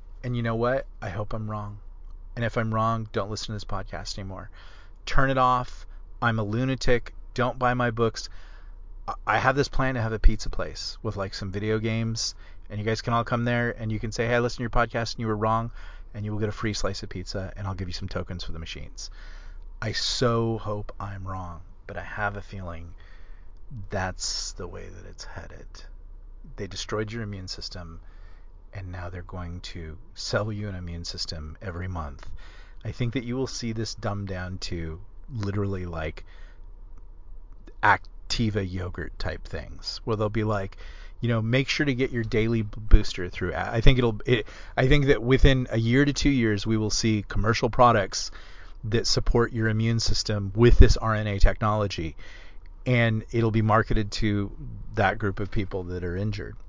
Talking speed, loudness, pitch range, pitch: 195 wpm, -27 LUFS, 90-115 Hz, 105 Hz